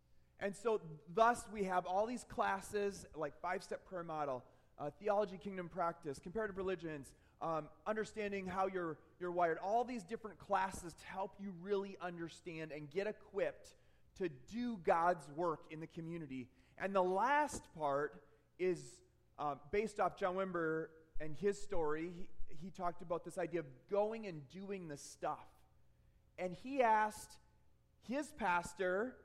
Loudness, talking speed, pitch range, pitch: -41 LUFS, 150 wpm, 160-200 Hz, 180 Hz